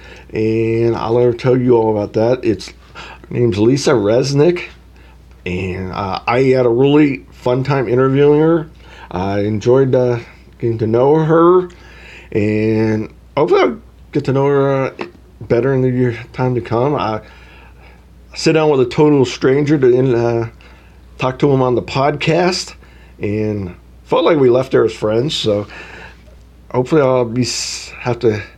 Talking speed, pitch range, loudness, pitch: 155 wpm, 90-135 Hz, -15 LUFS, 115 Hz